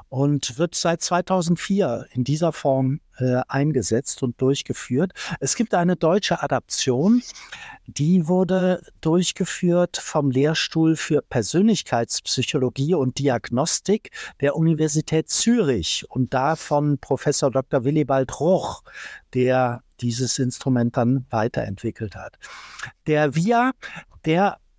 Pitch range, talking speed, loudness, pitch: 130-175 Hz, 105 wpm, -22 LUFS, 145 Hz